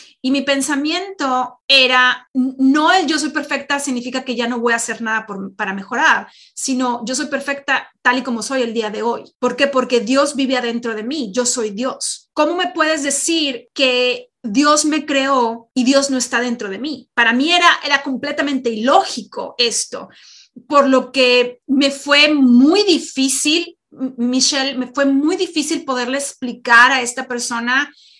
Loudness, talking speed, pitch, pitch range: -16 LUFS, 175 wpm, 265 Hz, 245-285 Hz